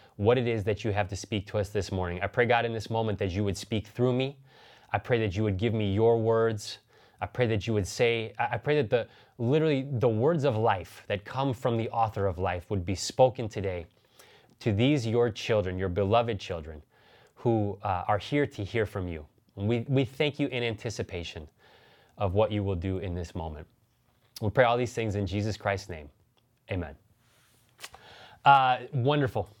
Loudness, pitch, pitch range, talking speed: -28 LUFS, 110 Hz, 100-120 Hz, 205 wpm